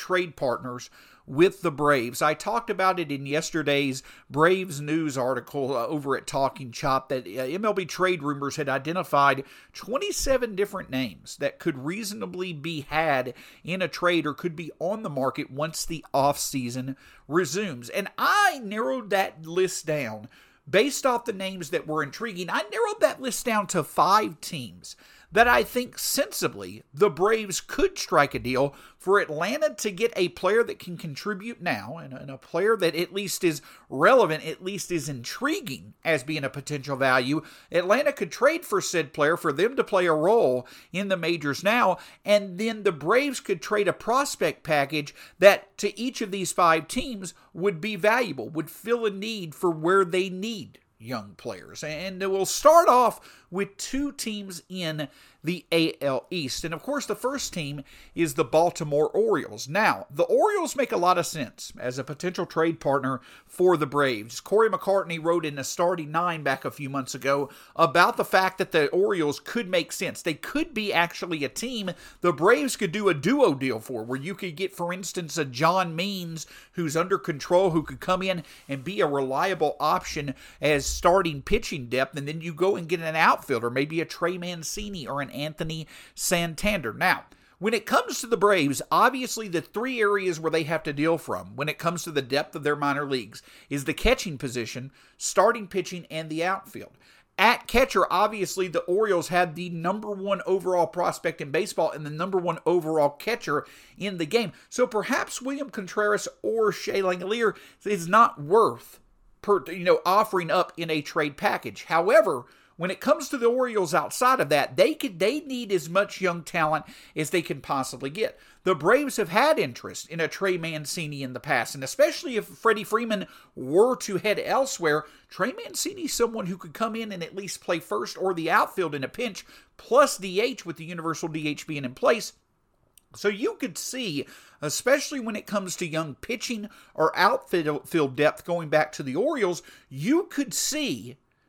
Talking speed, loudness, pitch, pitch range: 185 wpm, -25 LUFS, 175 Hz, 150-210 Hz